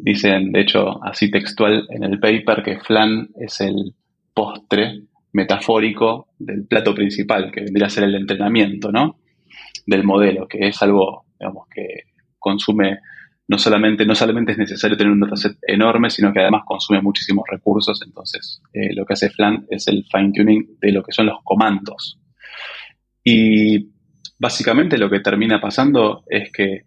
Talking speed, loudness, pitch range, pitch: 160 wpm, -17 LUFS, 100-110 Hz, 105 Hz